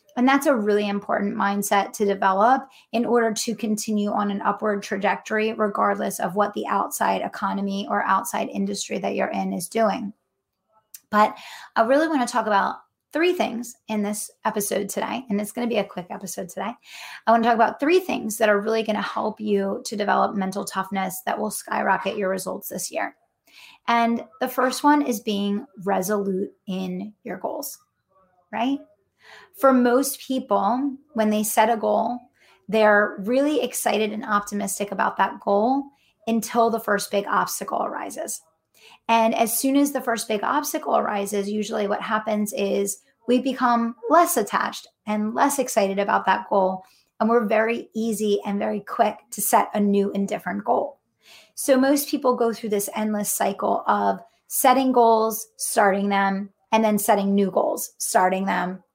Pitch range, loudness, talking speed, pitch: 200-235 Hz, -23 LUFS, 170 wpm, 215 Hz